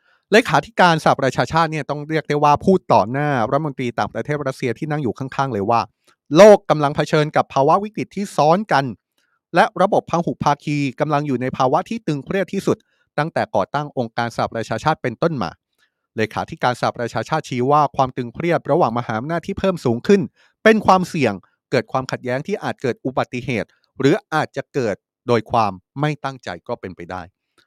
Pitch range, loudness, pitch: 120-165 Hz, -19 LUFS, 140 Hz